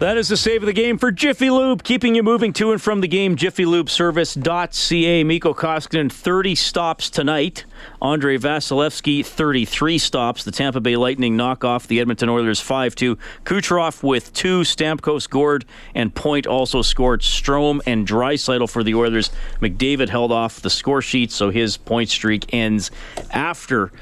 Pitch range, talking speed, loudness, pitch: 120-170 Hz, 165 wpm, -18 LUFS, 140 Hz